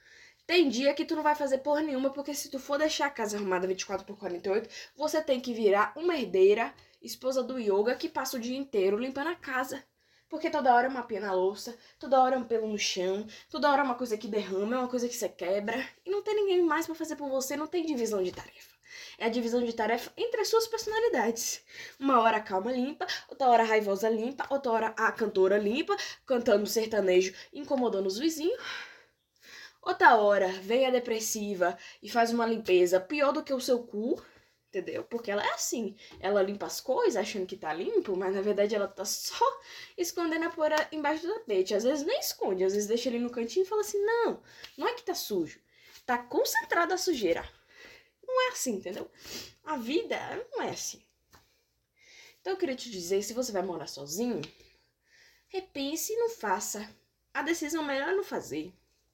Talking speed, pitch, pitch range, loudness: 200 wpm, 260 Hz, 215-345 Hz, -30 LUFS